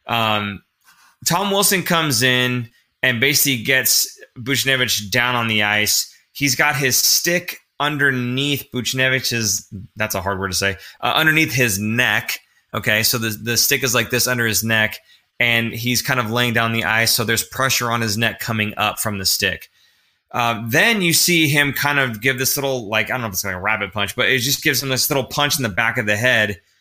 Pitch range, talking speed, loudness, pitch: 110-135 Hz, 210 wpm, -17 LUFS, 120 Hz